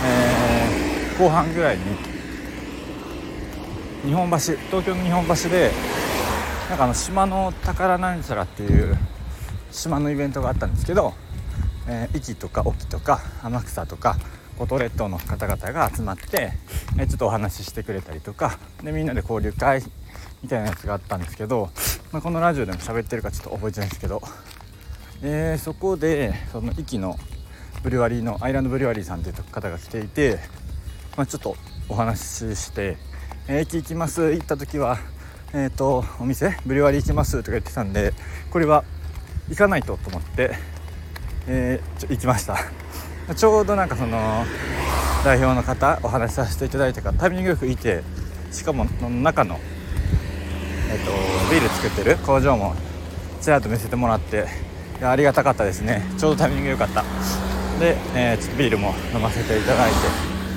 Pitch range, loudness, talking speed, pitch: 85-135 Hz, -23 LUFS, 350 characters per minute, 105 Hz